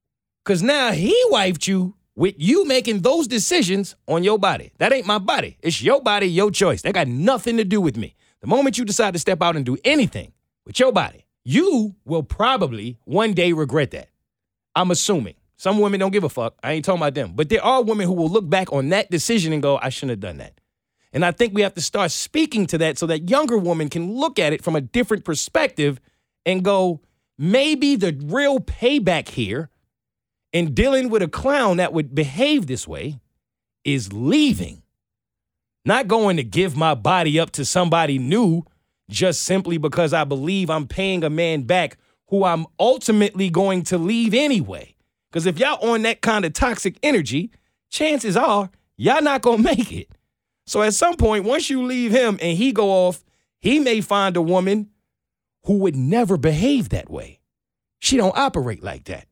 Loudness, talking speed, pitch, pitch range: -19 LUFS, 195 wpm, 190 Hz, 160-225 Hz